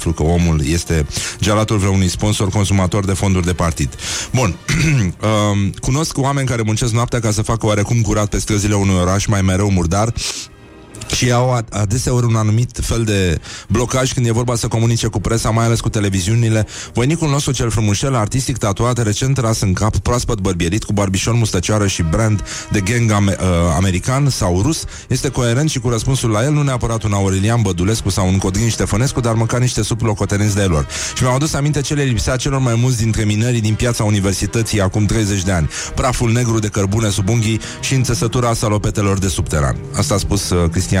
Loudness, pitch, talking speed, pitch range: -16 LUFS, 110 Hz, 185 wpm, 100-120 Hz